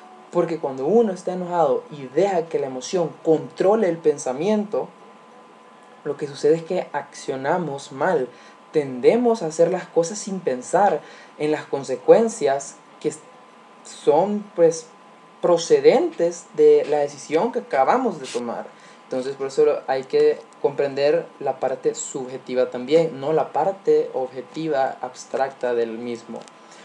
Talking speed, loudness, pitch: 130 wpm, -22 LUFS, 175 Hz